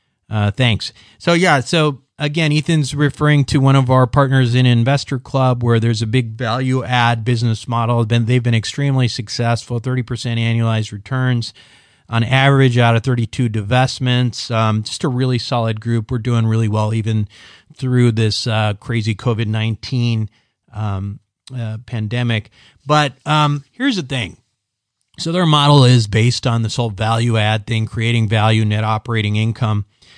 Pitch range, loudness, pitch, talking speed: 110-130 Hz, -16 LUFS, 120 Hz, 160 wpm